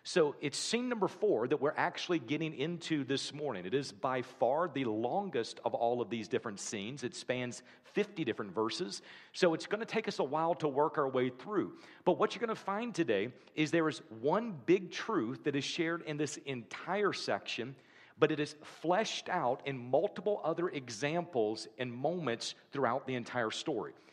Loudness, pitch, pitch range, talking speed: -35 LUFS, 155 Hz, 130-180 Hz, 190 wpm